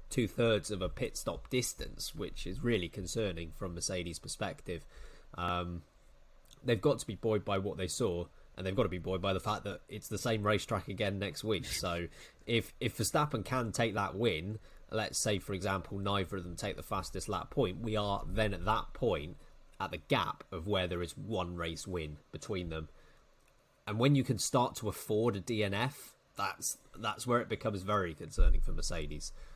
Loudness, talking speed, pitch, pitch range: -35 LUFS, 195 wpm, 100 Hz, 90-110 Hz